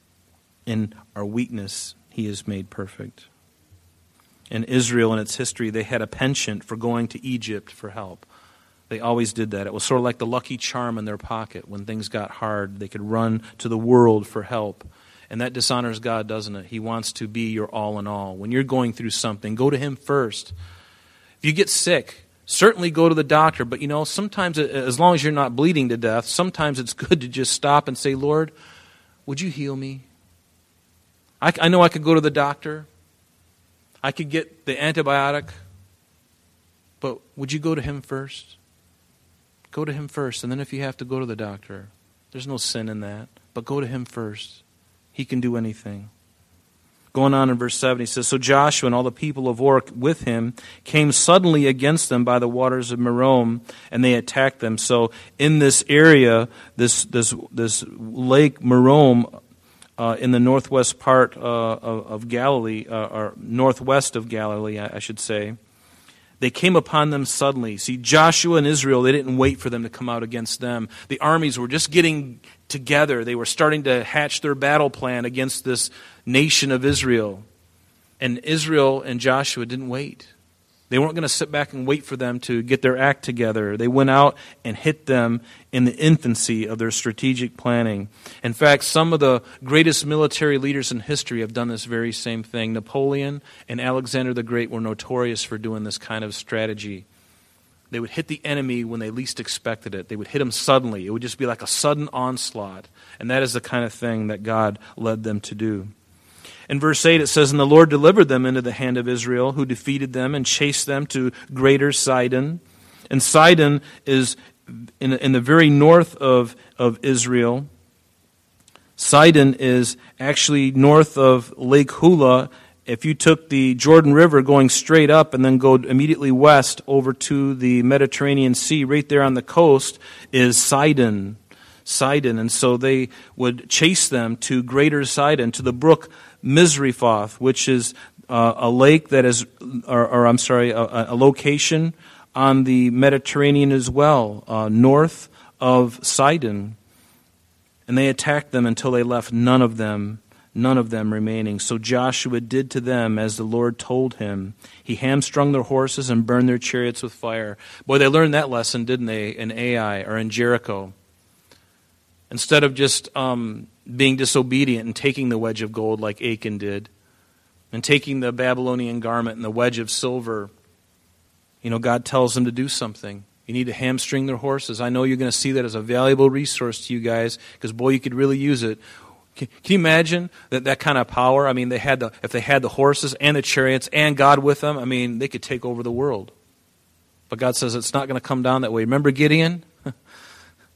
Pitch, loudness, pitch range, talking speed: 125 Hz, -19 LUFS, 110-140 Hz, 190 wpm